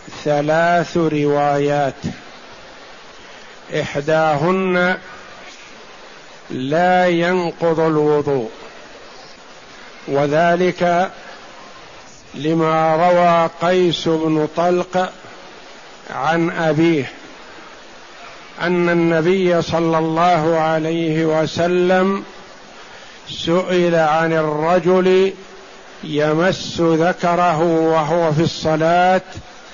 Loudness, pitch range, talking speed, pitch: -17 LUFS, 160-175 Hz, 55 wpm, 165 Hz